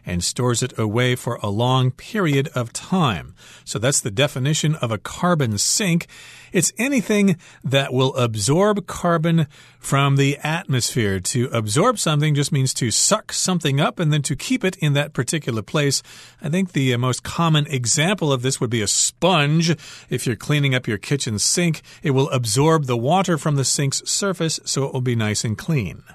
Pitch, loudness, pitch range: 140 Hz, -20 LUFS, 125-160 Hz